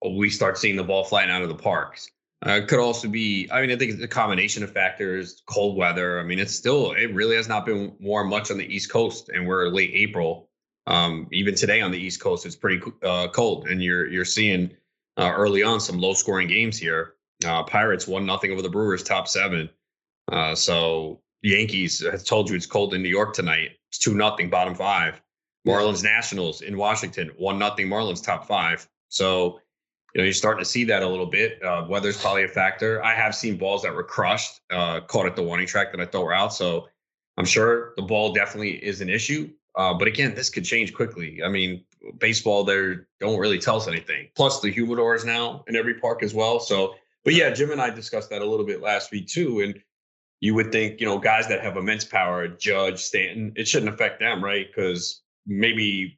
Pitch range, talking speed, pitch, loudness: 90-110 Hz, 220 wpm, 100 Hz, -23 LUFS